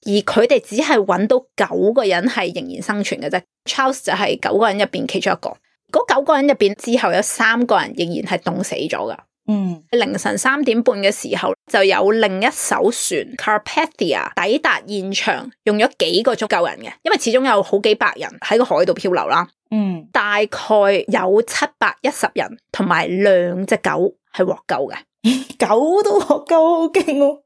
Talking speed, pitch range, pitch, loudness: 285 characters per minute, 200-270 Hz, 230 Hz, -17 LUFS